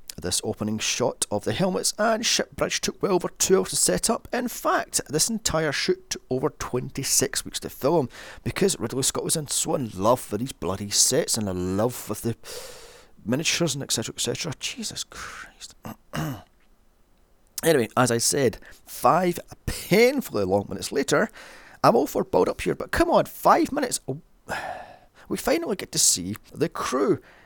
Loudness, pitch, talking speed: -24 LUFS, 155 Hz, 175 wpm